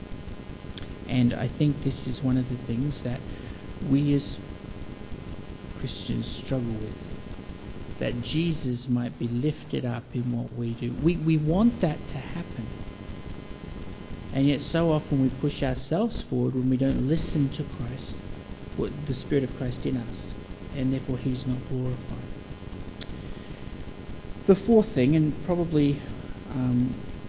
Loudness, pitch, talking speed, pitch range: -27 LUFS, 130 Hz, 135 wpm, 120-145 Hz